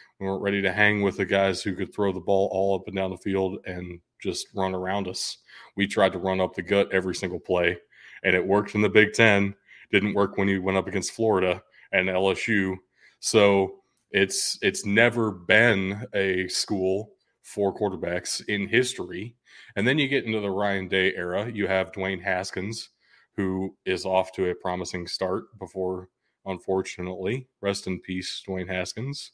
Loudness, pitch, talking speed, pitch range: -25 LUFS, 95 Hz, 180 wpm, 95-100 Hz